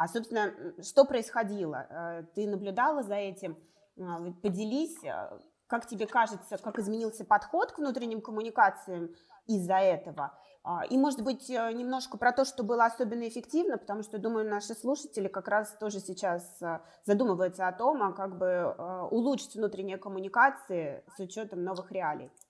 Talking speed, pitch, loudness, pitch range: 135 wpm, 215 Hz, -32 LUFS, 190-240 Hz